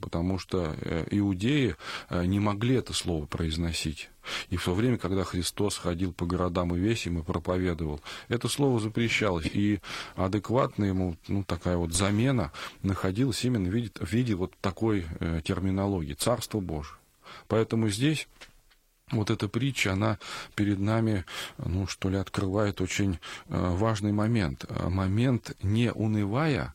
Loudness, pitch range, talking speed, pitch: -29 LUFS, 90-110 Hz, 135 wpm, 100 Hz